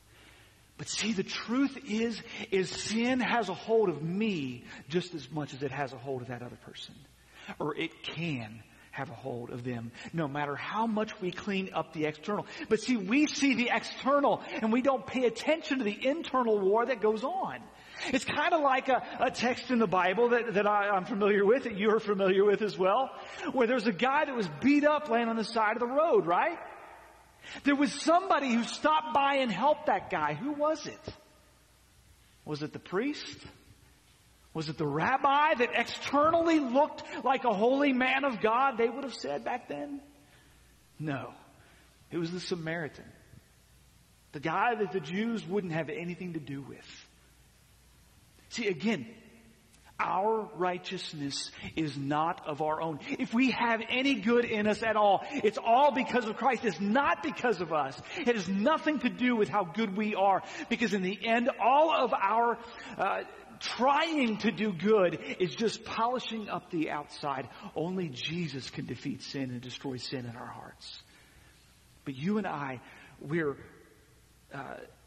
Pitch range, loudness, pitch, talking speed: 160-255 Hz, -30 LUFS, 215 Hz, 175 wpm